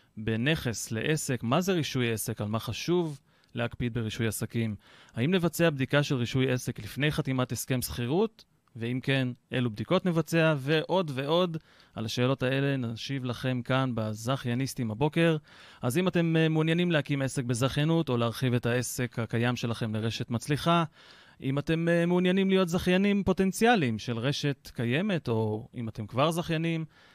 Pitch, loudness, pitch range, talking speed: 135 Hz, -29 LUFS, 120-165 Hz, 150 wpm